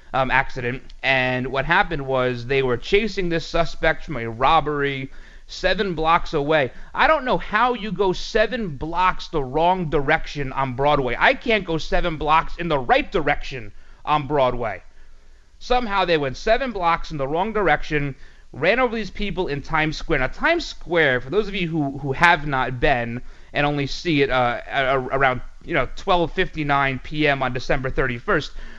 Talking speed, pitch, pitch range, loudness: 170 wpm, 155 Hz, 135-180 Hz, -21 LUFS